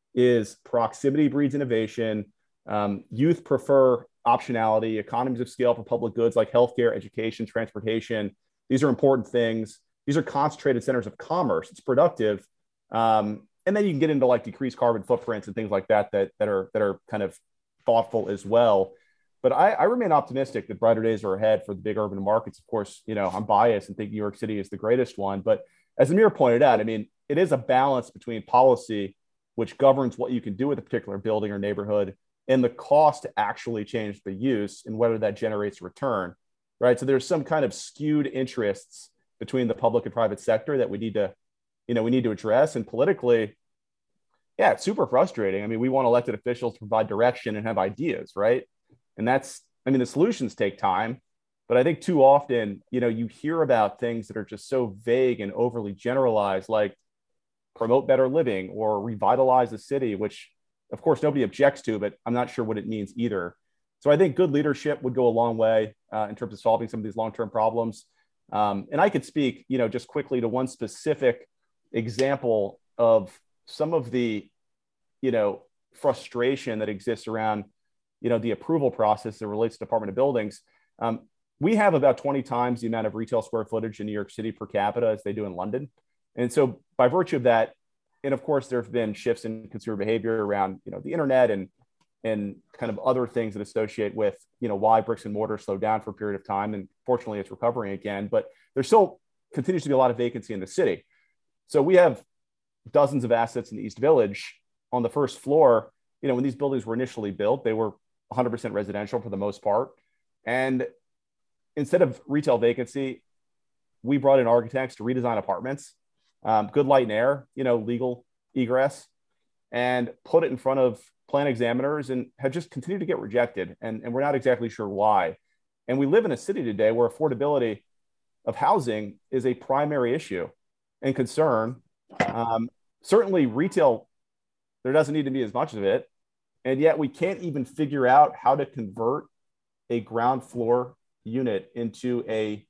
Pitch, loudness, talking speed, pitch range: 120 Hz, -25 LUFS, 200 wpm, 110-135 Hz